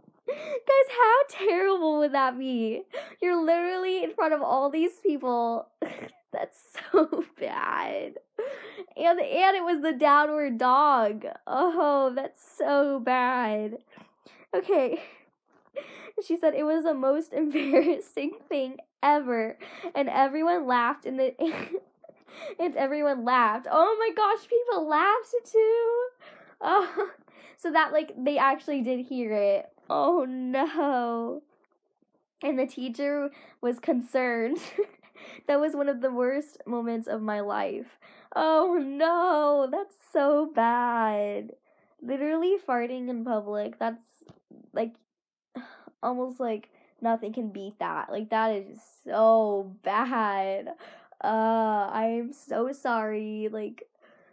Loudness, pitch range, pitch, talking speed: -27 LUFS, 240-335 Hz, 285 Hz, 115 wpm